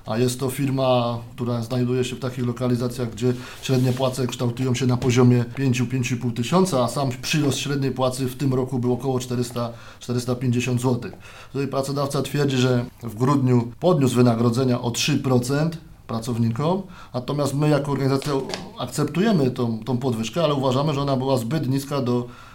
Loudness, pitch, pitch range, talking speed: -22 LUFS, 125 Hz, 125-135 Hz, 155 wpm